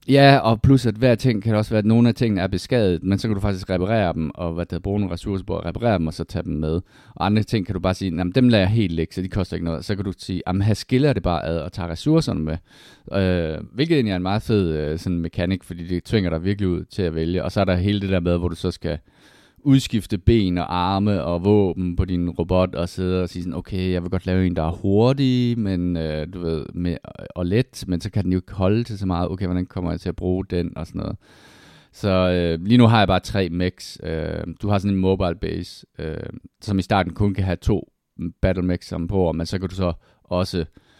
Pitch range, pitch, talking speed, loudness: 85-105 Hz, 95 Hz, 265 wpm, -22 LUFS